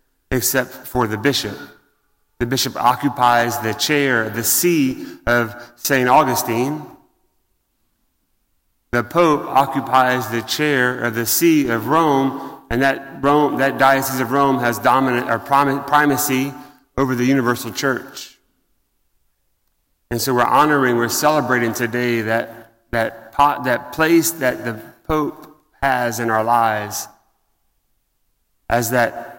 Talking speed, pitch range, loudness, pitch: 130 wpm, 115-140 Hz, -18 LUFS, 125 Hz